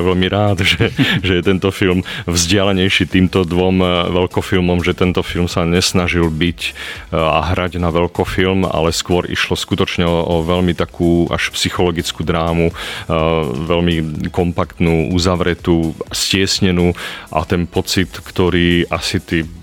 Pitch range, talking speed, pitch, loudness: 85-95 Hz, 125 wpm, 90 Hz, -15 LUFS